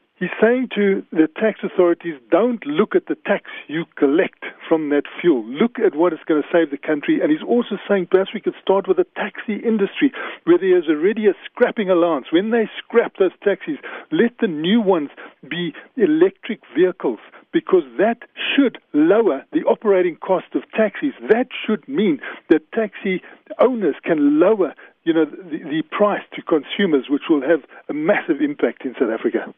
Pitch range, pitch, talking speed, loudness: 185-300 Hz, 225 Hz, 180 wpm, -19 LUFS